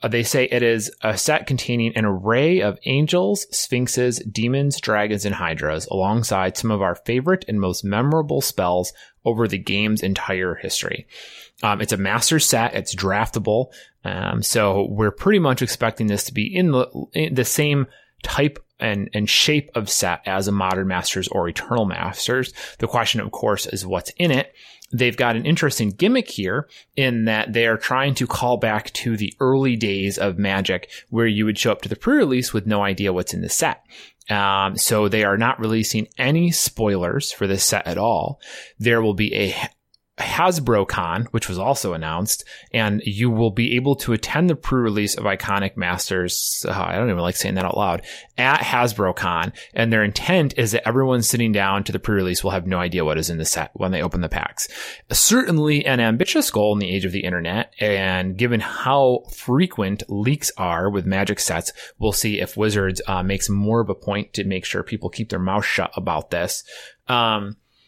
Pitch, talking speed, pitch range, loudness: 110 Hz, 195 wpm, 100-125 Hz, -20 LUFS